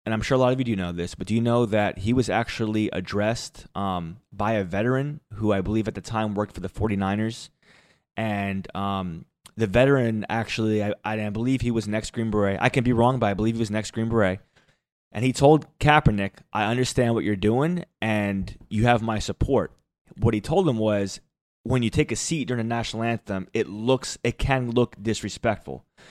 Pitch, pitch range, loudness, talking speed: 110 Hz, 105-125 Hz, -24 LUFS, 215 wpm